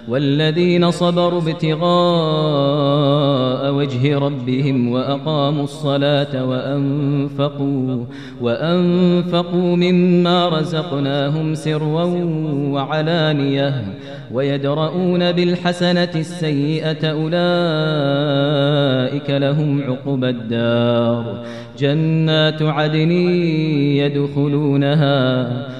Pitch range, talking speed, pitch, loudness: 140-160 Hz, 55 wpm, 145 Hz, -17 LUFS